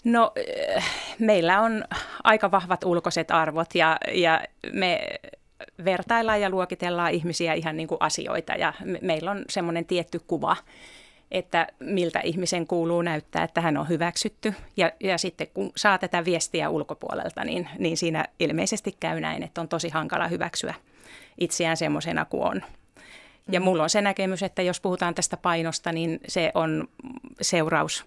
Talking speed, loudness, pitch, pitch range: 150 wpm, -25 LUFS, 175 Hz, 165-195 Hz